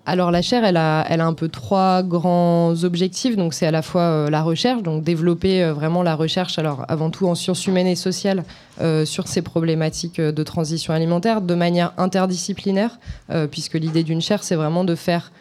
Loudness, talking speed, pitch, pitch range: -20 LUFS, 210 wpm, 175 Hz, 160-185 Hz